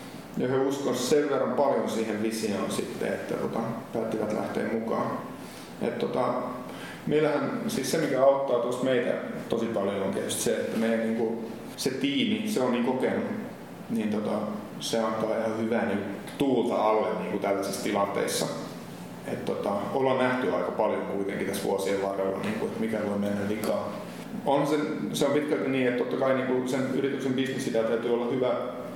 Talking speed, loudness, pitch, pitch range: 160 wpm, -28 LUFS, 120 Hz, 110-135 Hz